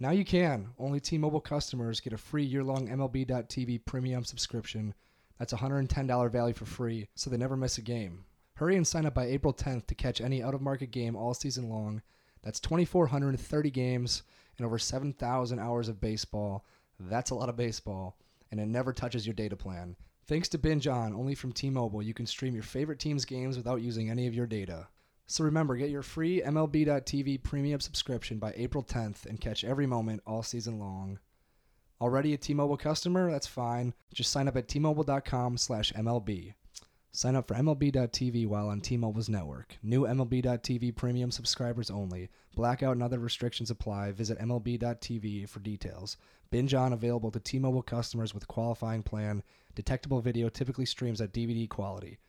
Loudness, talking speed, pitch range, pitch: -33 LUFS, 180 wpm, 110-135 Hz, 120 Hz